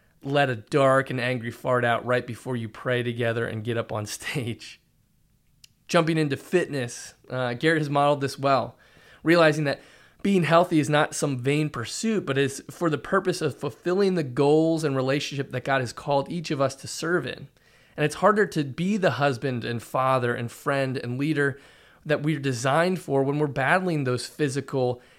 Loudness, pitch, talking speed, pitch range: -25 LUFS, 140 Hz, 185 wpm, 125-155 Hz